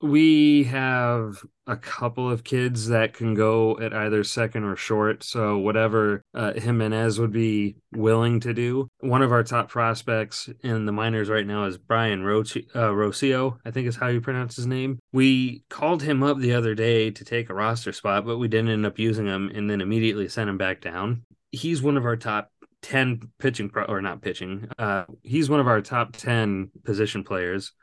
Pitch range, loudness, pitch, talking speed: 105-125 Hz, -24 LUFS, 115 Hz, 200 wpm